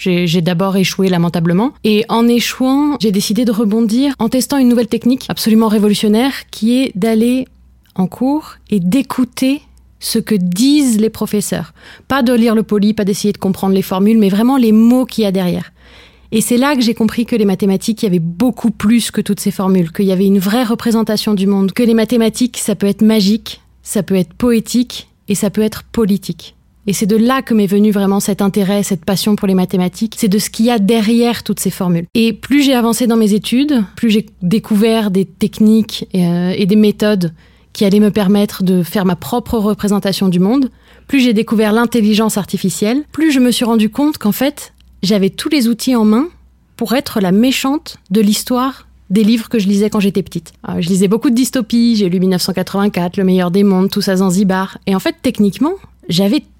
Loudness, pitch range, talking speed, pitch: -13 LUFS, 195-235 Hz, 210 wpm, 215 Hz